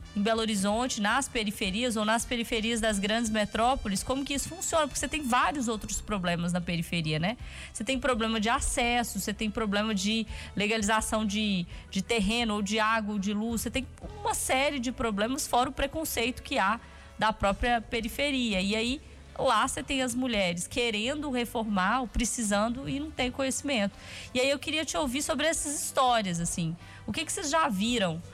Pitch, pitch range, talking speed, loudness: 230 Hz, 210-260 Hz, 185 wpm, -29 LUFS